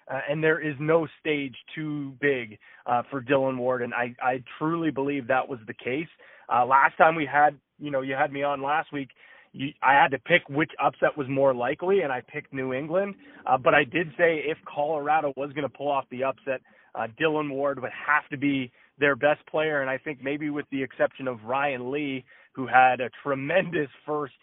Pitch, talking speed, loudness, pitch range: 140 Hz, 215 wpm, -26 LUFS, 135-150 Hz